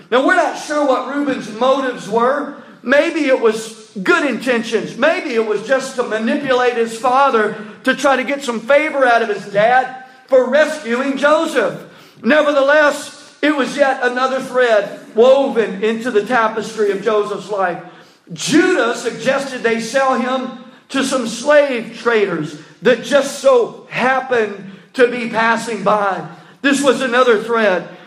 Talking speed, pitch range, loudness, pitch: 145 wpm, 220-275 Hz, -16 LUFS, 250 Hz